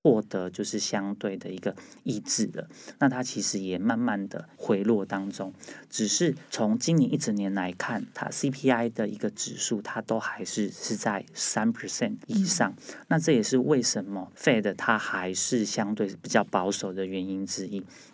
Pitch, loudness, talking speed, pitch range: 105 Hz, -28 LUFS, 275 characters per minute, 95-140 Hz